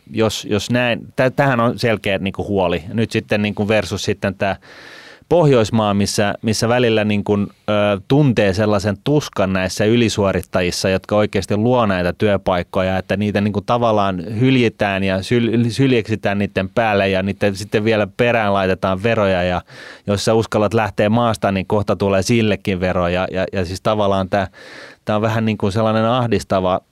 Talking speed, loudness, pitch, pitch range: 155 wpm, -17 LUFS, 105 Hz, 95-115 Hz